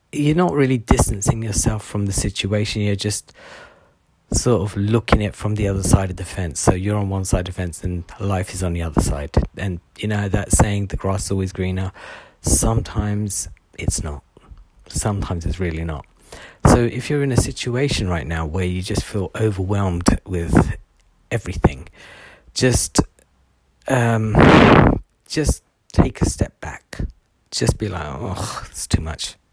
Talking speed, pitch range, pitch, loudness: 170 wpm, 90-105 Hz, 95 Hz, -20 LUFS